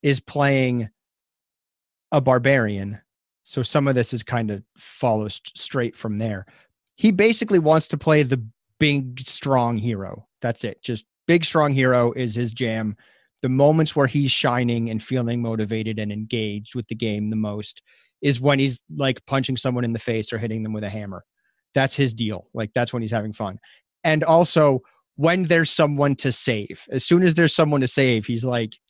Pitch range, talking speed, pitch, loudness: 110-140 Hz, 185 wpm, 125 Hz, -21 LUFS